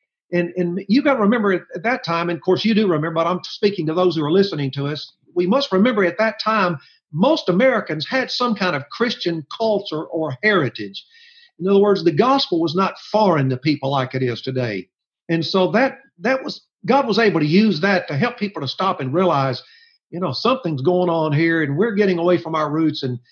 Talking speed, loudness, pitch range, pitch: 225 wpm, -19 LUFS, 160-215 Hz, 180 Hz